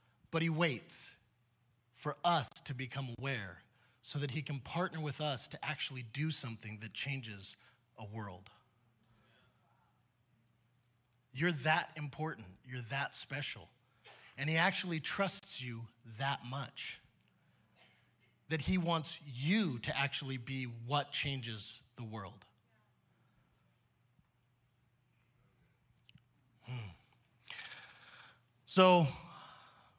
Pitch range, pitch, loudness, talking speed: 115-150 Hz, 125 Hz, -37 LUFS, 100 wpm